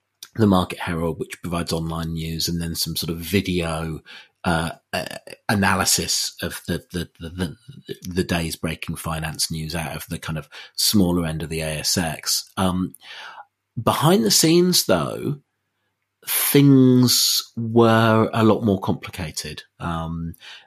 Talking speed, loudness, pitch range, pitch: 135 wpm, -21 LUFS, 80-110 Hz, 90 Hz